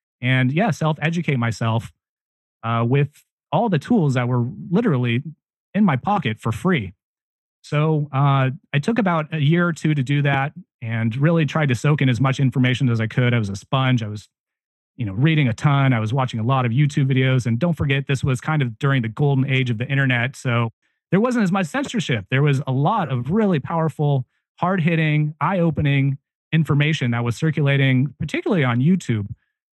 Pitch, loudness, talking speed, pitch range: 140 Hz, -20 LUFS, 195 wpm, 125-155 Hz